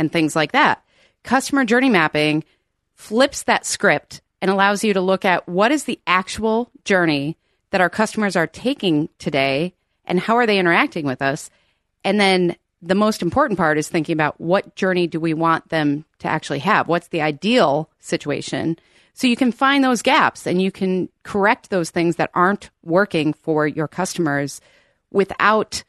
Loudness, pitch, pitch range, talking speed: -19 LUFS, 180 Hz, 160-205 Hz, 175 wpm